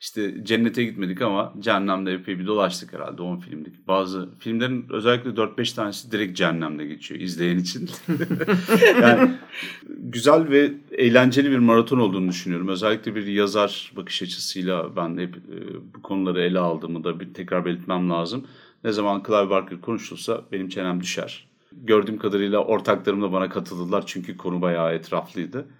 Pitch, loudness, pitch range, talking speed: 100 Hz, -22 LUFS, 90-115 Hz, 150 wpm